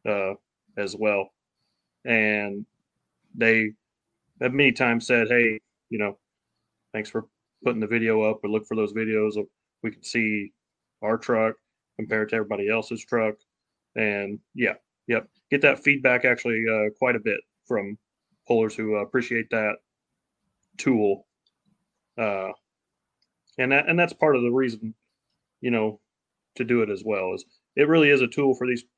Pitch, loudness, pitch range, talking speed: 110 Hz, -24 LUFS, 105-125 Hz, 155 wpm